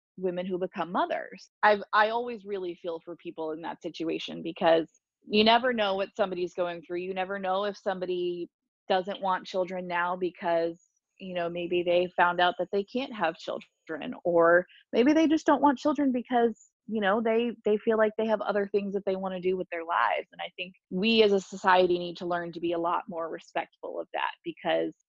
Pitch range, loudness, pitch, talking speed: 175-215 Hz, -28 LUFS, 185 Hz, 210 wpm